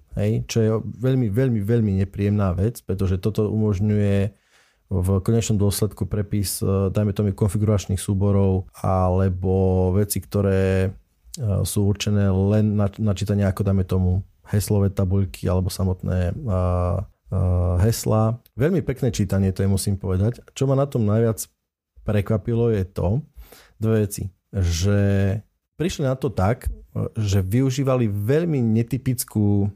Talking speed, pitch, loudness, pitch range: 130 wpm, 100 Hz, -22 LUFS, 95-110 Hz